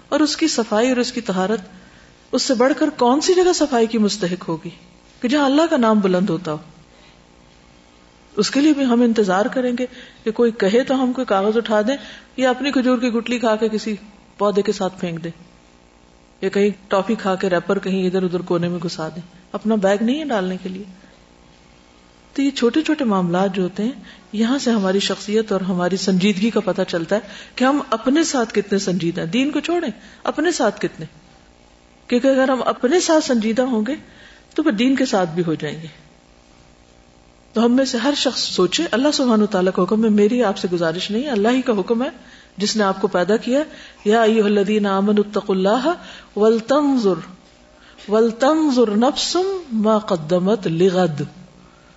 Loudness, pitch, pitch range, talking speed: -19 LUFS, 210 Hz, 180-250 Hz, 185 wpm